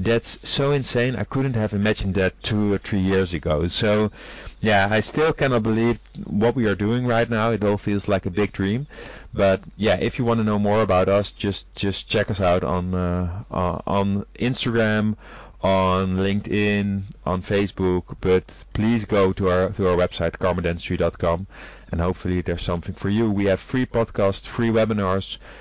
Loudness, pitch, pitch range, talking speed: -22 LUFS, 100 Hz, 95-110 Hz, 180 wpm